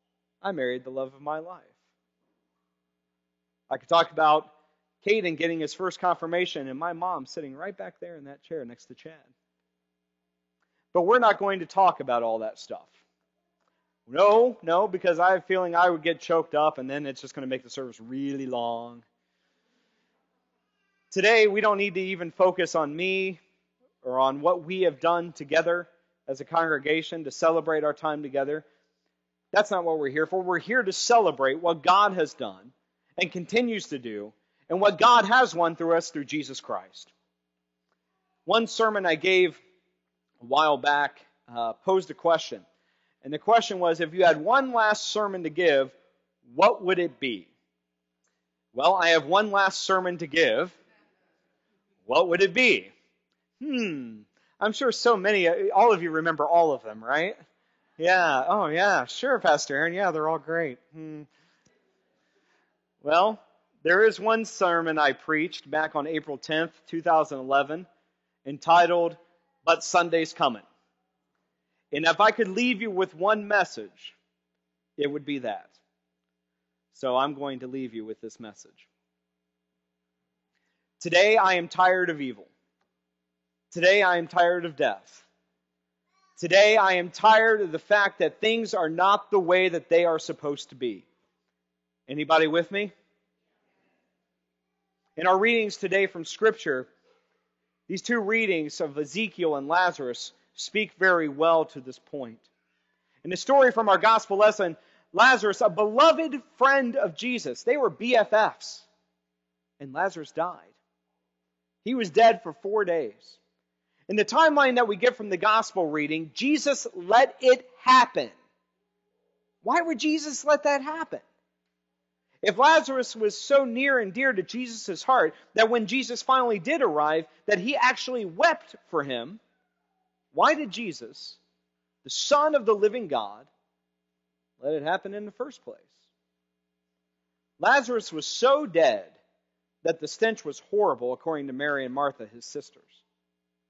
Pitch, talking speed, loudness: 165 Hz, 155 wpm, -24 LUFS